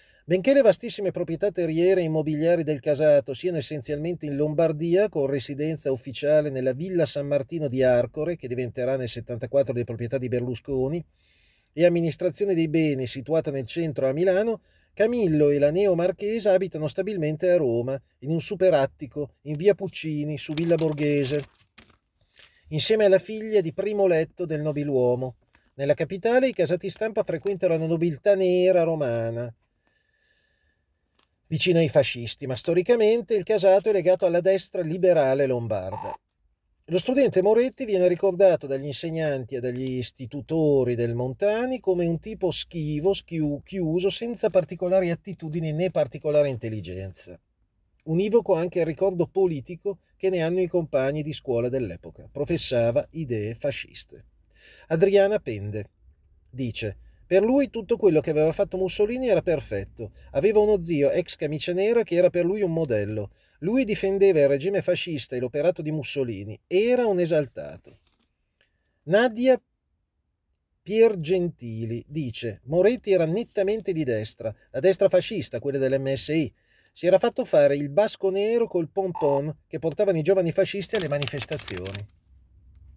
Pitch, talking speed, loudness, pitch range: 160 Hz, 140 wpm, -24 LUFS, 135-190 Hz